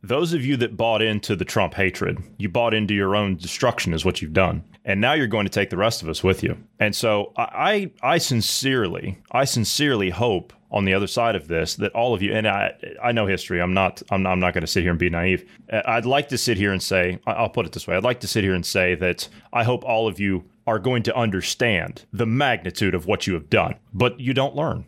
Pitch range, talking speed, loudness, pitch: 95-120 Hz, 260 wpm, -22 LUFS, 105 Hz